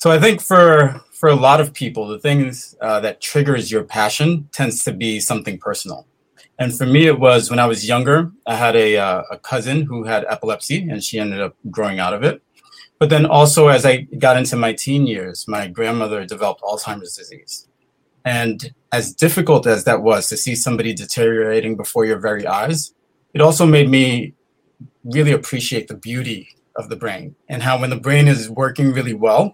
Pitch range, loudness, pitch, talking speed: 115-145 Hz, -16 LUFS, 130 Hz, 195 wpm